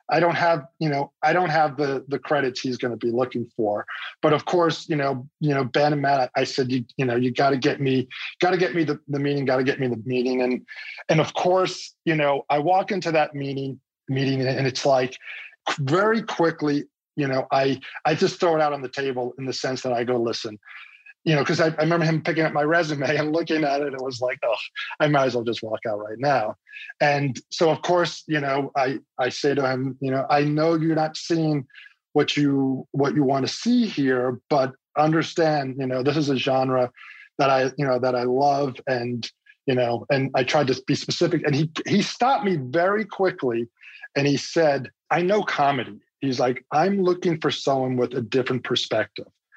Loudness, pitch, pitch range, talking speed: -23 LUFS, 140 Hz, 130-160 Hz, 225 wpm